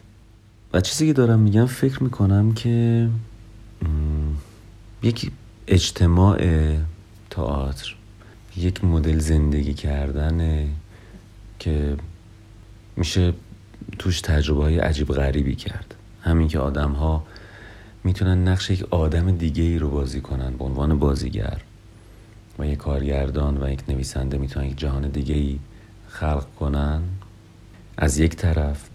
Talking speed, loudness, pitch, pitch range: 115 wpm, -22 LUFS, 90 Hz, 75-105 Hz